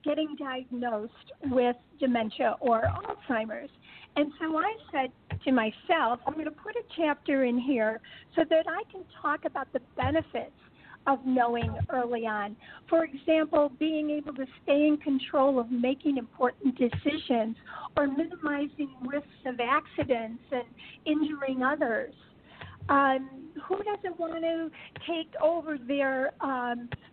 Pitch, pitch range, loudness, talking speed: 280 Hz, 255-310 Hz, -29 LUFS, 135 wpm